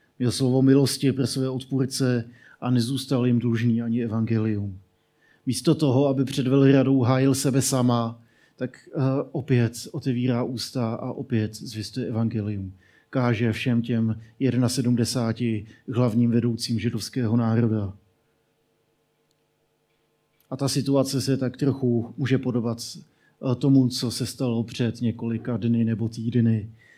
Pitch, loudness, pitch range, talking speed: 120 Hz, -24 LUFS, 115-130 Hz, 120 wpm